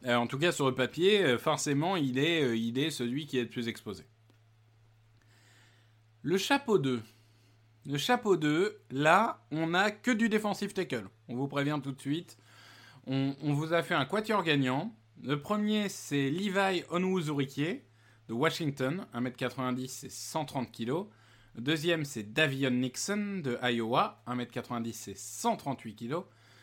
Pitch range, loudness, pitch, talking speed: 115-160 Hz, -31 LUFS, 135 Hz, 155 wpm